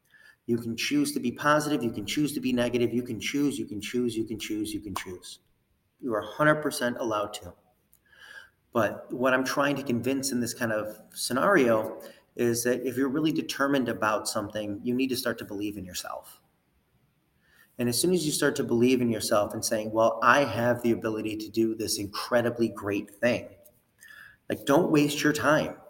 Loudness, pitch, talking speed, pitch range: -27 LUFS, 120 Hz, 195 wpm, 110-135 Hz